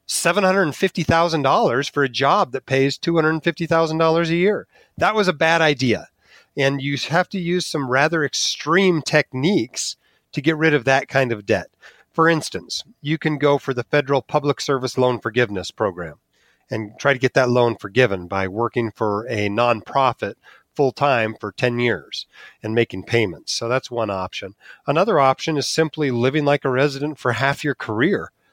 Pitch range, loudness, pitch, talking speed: 120-160 Hz, -20 LUFS, 140 Hz, 170 wpm